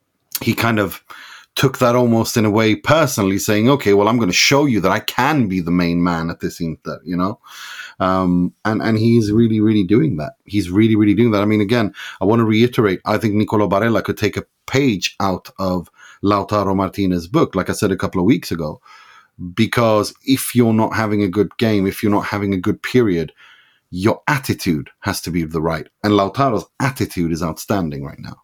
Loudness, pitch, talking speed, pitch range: -17 LUFS, 105 Hz, 215 wpm, 95-115 Hz